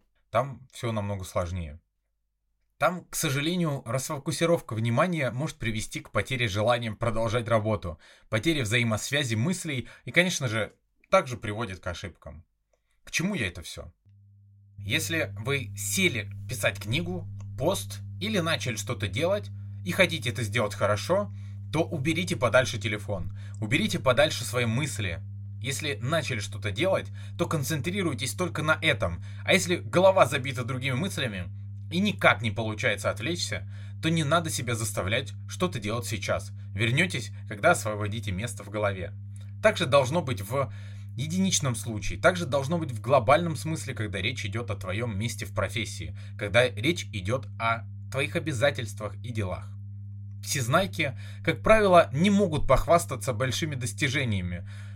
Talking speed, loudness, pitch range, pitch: 135 wpm, -27 LUFS, 100-135 Hz, 110 Hz